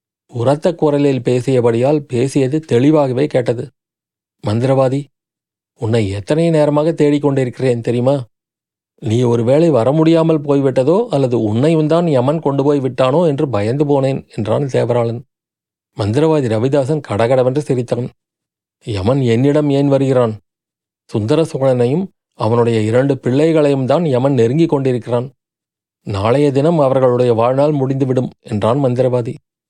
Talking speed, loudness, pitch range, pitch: 105 wpm, -15 LUFS, 120-145 Hz, 135 Hz